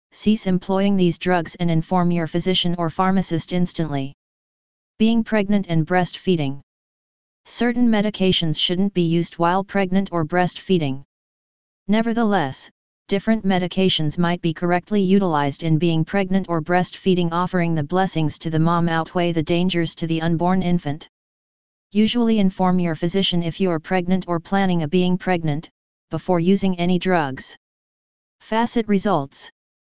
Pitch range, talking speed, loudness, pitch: 165-190 Hz, 135 wpm, -20 LUFS, 180 Hz